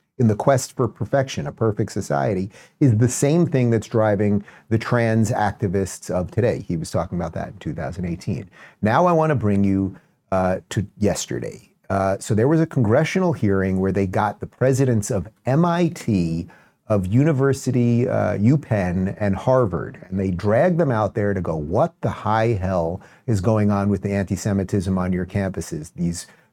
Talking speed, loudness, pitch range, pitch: 175 wpm, -21 LUFS, 95-130 Hz, 105 Hz